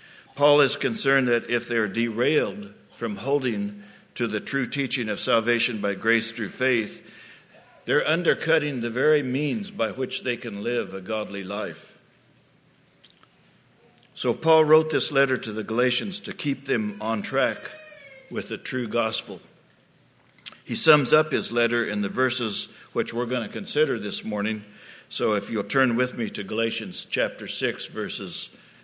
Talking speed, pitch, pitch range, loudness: 160 wpm, 120 Hz, 110-140 Hz, -25 LUFS